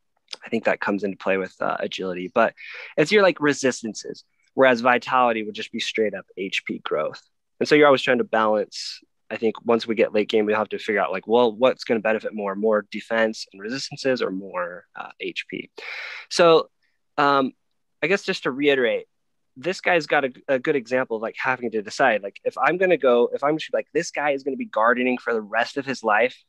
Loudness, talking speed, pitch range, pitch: -22 LUFS, 220 wpm, 110-145 Hz, 125 Hz